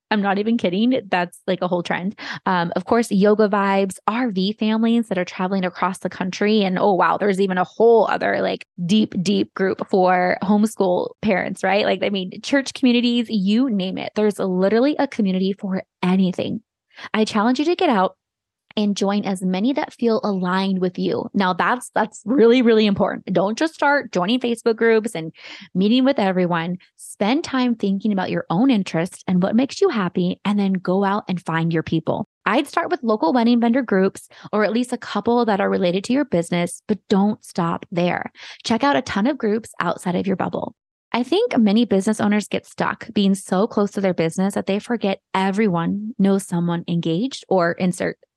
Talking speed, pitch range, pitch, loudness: 195 wpm, 185-230 Hz, 205 Hz, -20 LUFS